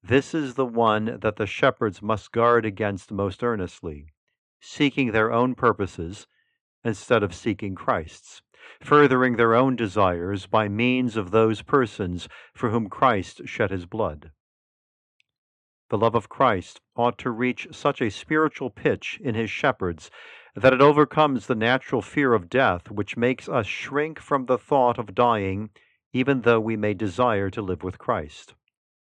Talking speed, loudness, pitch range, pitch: 155 wpm, -23 LUFS, 100-130 Hz, 115 Hz